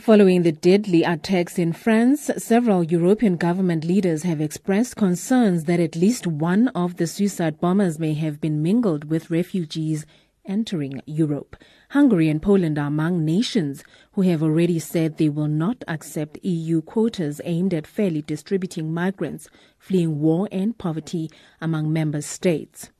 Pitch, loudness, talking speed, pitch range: 170 Hz, -22 LUFS, 150 wpm, 160-195 Hz